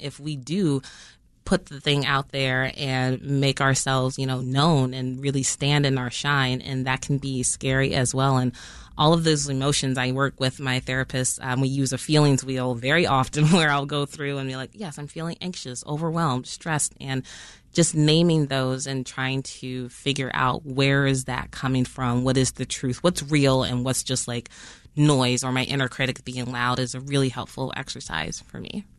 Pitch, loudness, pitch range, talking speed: 135 Hz, -24 LUFS, 130-145 Hz, 200 wpm